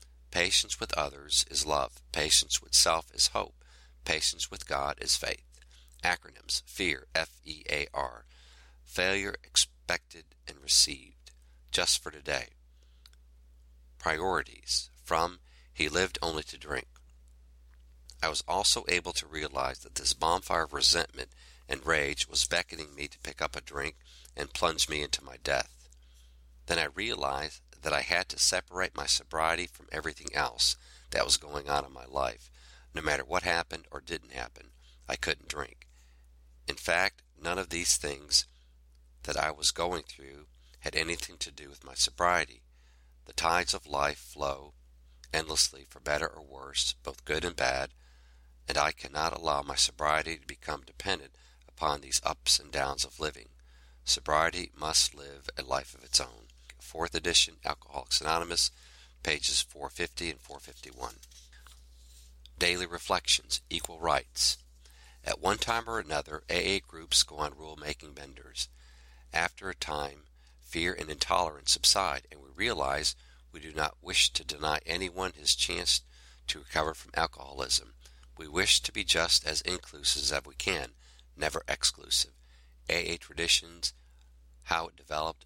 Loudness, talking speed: -30 LUFS, 145 wpm